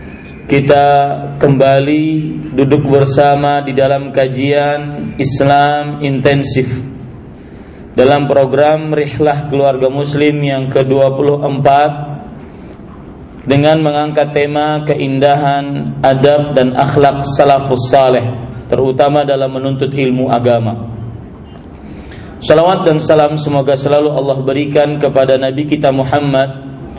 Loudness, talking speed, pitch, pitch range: -11 LUFS, 90 wpm, 140 Hz, 135-145 Hz